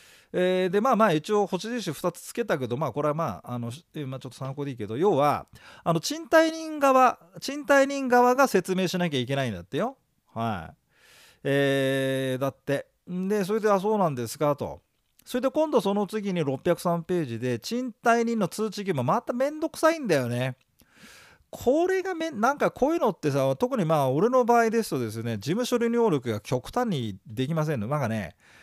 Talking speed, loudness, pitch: 355 characters per minute, -26 LUFS, 180 Hz